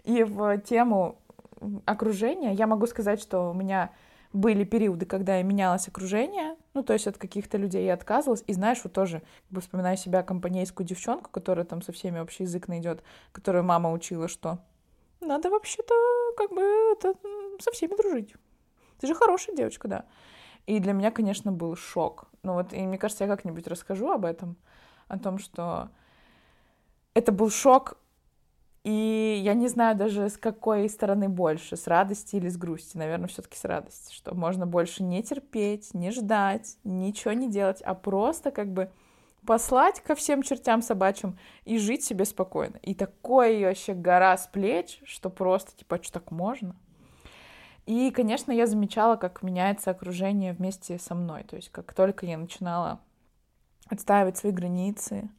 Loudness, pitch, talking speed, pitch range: -27 LUFS, 200 Hz, 165 wpm, 185-230 Hz